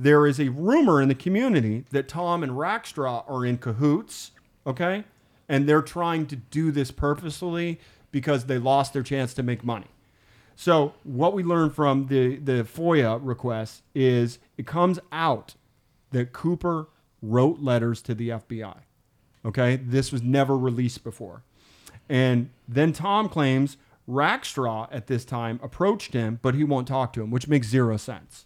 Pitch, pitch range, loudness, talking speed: 135 Hz, 120-150 Hz, -25 LUFS, 160 wpm